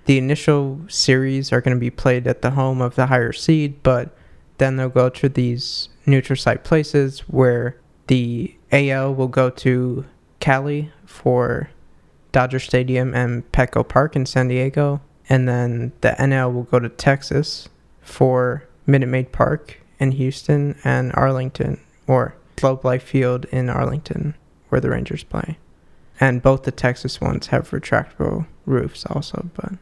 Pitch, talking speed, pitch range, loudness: 130 Hz, 155 wpm, 125-140 Hz, -19 LUFS